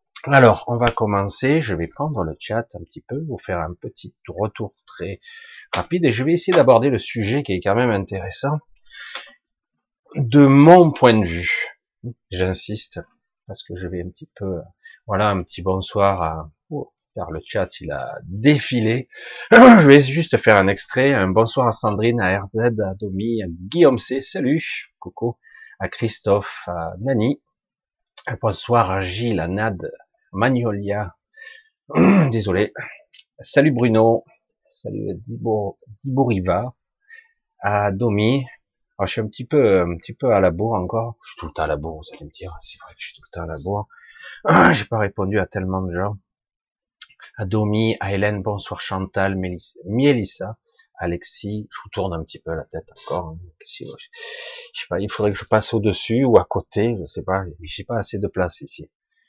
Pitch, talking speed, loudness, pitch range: 110 Hz, 175 wpm, -19 LUFS, 95-135 Hz